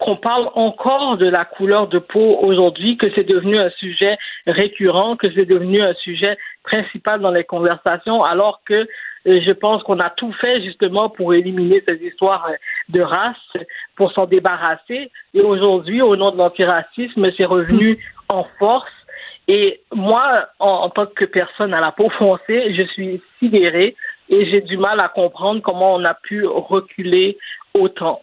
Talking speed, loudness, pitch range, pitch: 165 wpm, -16 LUFS, 185-220 Hz, 200 Hz